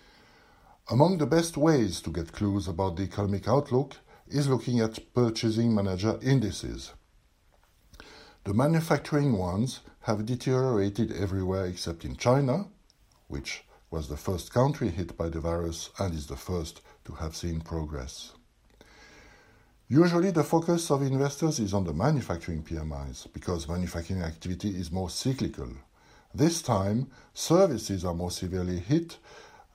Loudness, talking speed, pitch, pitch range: -29 LUFS, 135 wpm, 100 Hz, 85-130 Hz